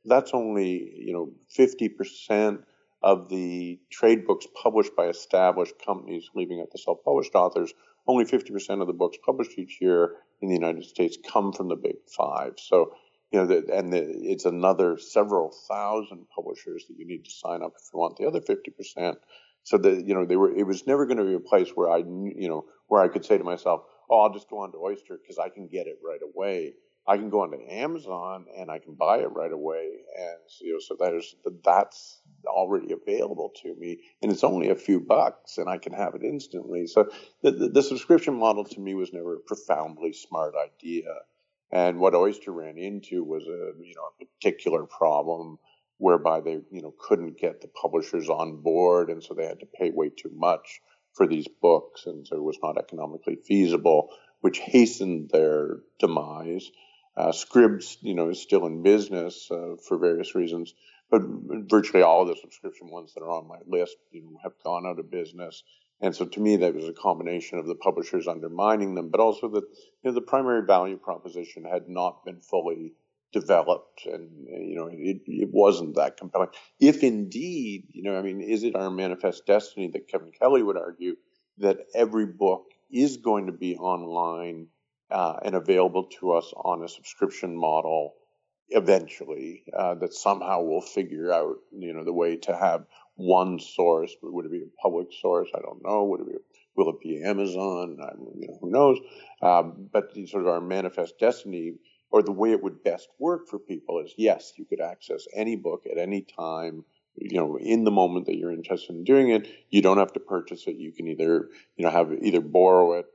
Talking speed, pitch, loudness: 200 wpm, 345 Hz, -25 LUFS